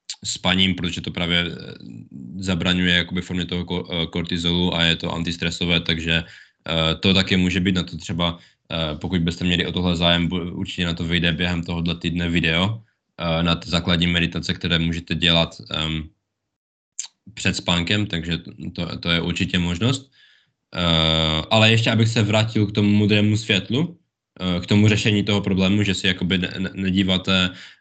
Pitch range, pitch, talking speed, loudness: 85-95 Hz, 90 Hz, 145 wpm, -20 LUFS